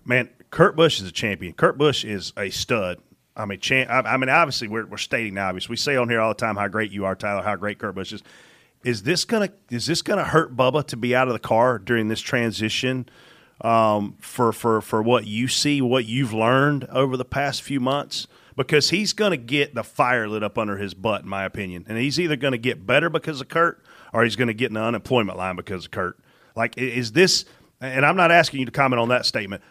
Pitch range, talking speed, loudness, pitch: 110-140 Hz, 240 wpm, -22 LUFS, 125 Hz